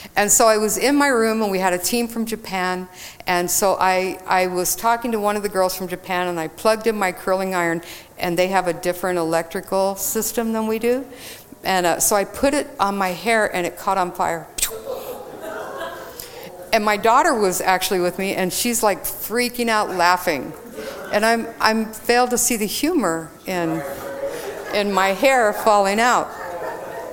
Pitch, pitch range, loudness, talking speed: 195 Hz, 180-225 Hz, -20 LUFS, 190 wpm